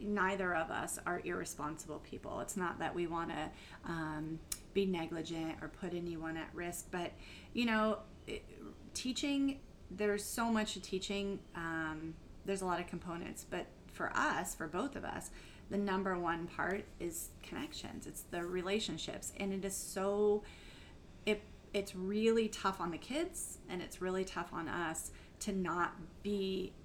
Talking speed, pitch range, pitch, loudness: 160 wpm, 170-205 Hz, 185 Hz, -39 LUFS